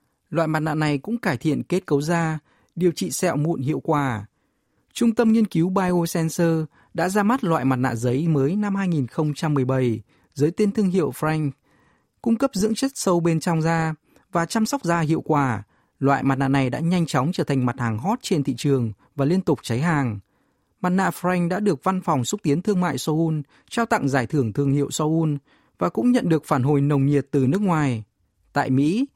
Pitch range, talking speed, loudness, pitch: 140-180 Hz, 210 wpm, -22 LUFS, 155 Hz